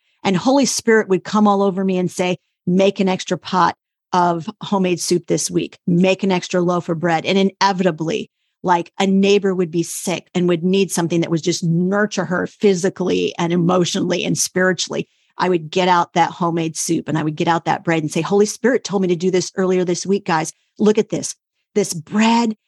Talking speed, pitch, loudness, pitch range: 210 wpm, 185 Hz, -18 LUFS, 175-195 Hz